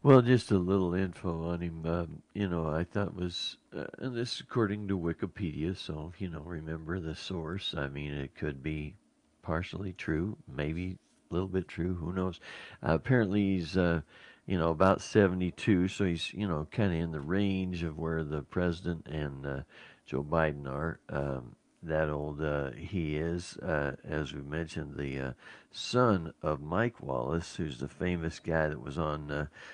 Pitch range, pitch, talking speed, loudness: 75-95 Hz, 85 Hz, 185 wpm, -33 LUFS